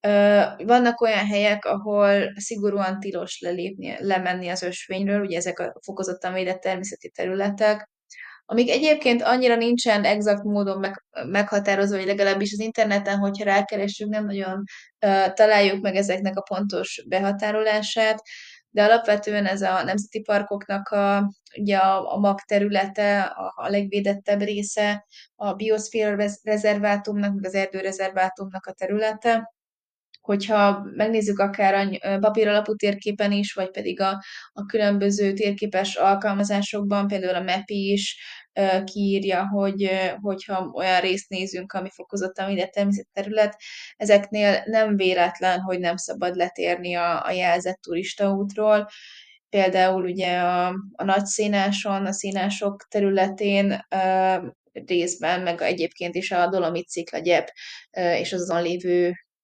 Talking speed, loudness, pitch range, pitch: 130 wpm, -23 LUFS, 190-210 Hz, 200 Hz